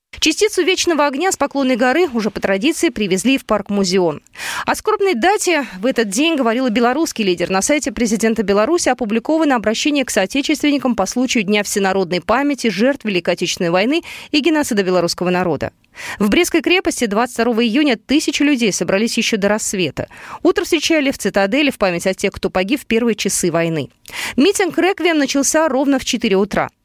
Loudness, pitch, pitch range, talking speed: -16 LUFS, 245 Hz, 200-300 Hz, 170 wpm